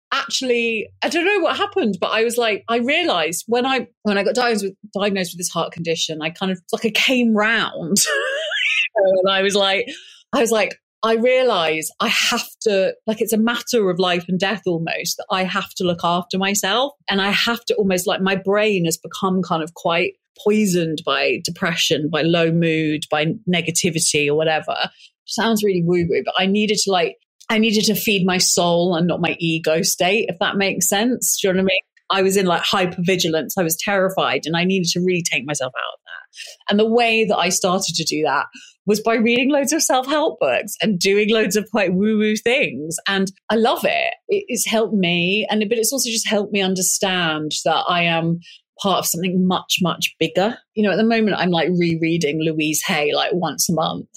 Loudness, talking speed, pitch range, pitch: -18 LUFS, 210 wpm, 170-220 Hz, 195 Hz